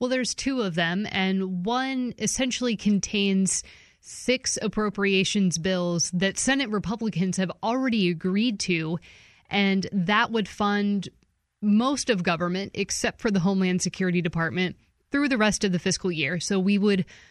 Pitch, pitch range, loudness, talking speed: 195 Hz, 185-220 Hz, -25 LUFS, 145 wpm